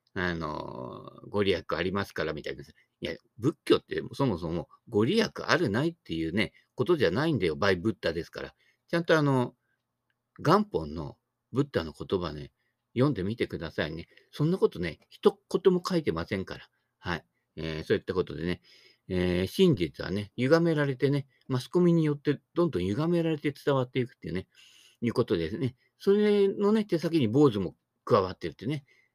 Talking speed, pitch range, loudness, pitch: 360 characters per minute, 100-170 Hz, -29 LUFS, 140 Hz